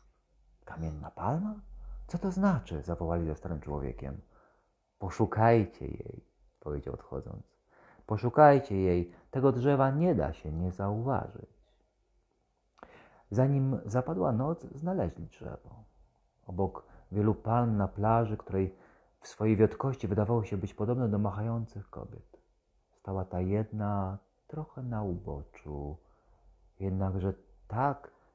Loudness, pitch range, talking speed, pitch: -31 LUFS, 90-120 Hz, 110 wpm, 105 Hz